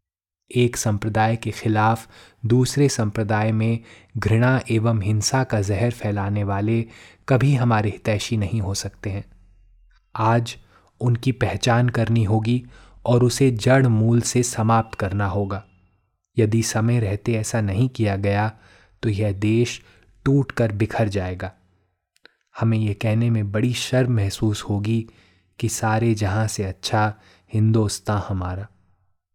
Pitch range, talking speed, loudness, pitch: 100-115 Hz, 130 wpm, -21 LUFS, 110 Hz